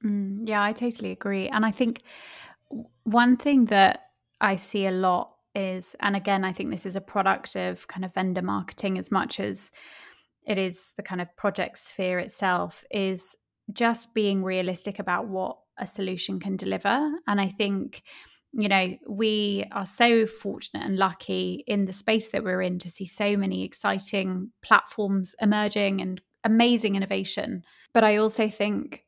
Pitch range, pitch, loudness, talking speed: 185-215 Hz, 200 Hz, -26 LUFS, 165 wpm